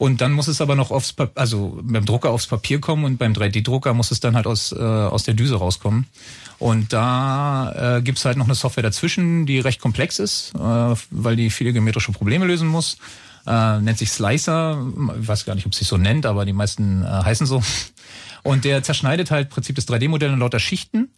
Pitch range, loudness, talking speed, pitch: 110-140 Hz, -20 LUFS, 220 wpm, 125 Hz